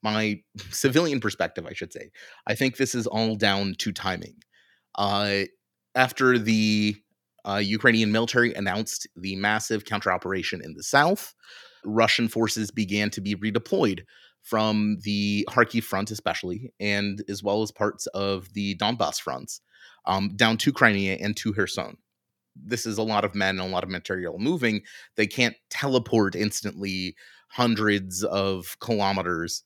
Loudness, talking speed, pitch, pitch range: -25 LUFS, 150 wpm, 105 Hz, 100-115 Hz